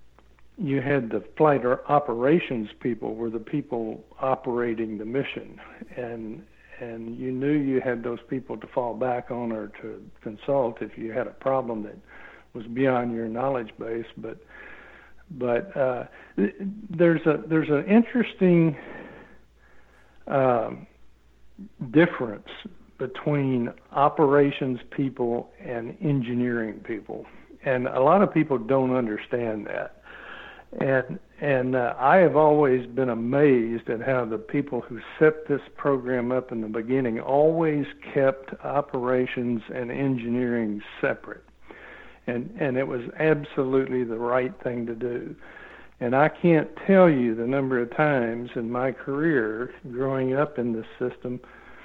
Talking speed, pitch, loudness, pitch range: 135 wpm, 130 Hz, -25 LUFS, 120-145 Hz